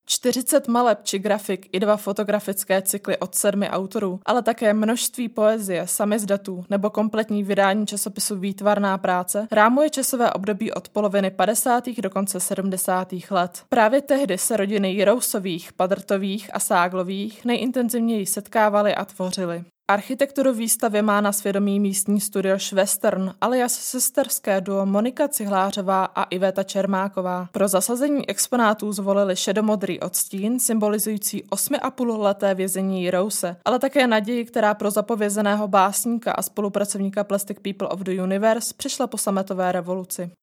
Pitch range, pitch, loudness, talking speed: 195-220 Hz, 205 Hz, -22 LUFS, 130 wpm